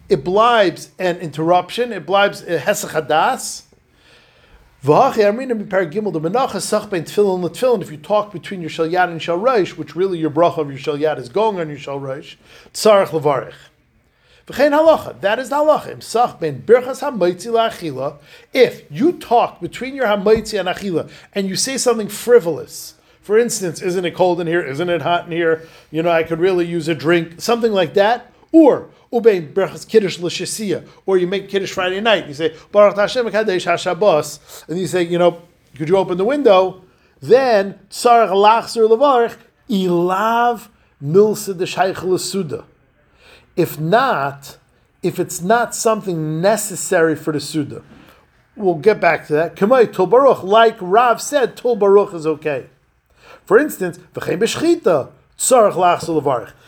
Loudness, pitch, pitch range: -17 LUFS, 185 Hz, 165-220 Hz